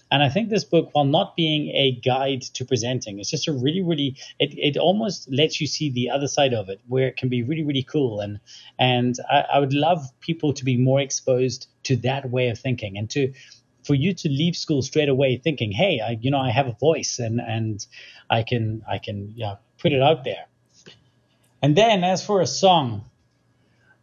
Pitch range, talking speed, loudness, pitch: 125-150 Hz, 215 wpm, -22 LUFS, 135 Hz